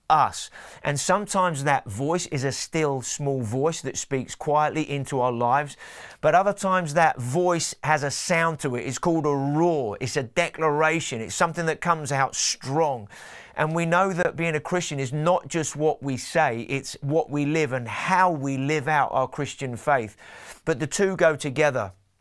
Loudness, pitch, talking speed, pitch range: -24 LUFS, 150 Hz, 185 wpm, 135-165 Hz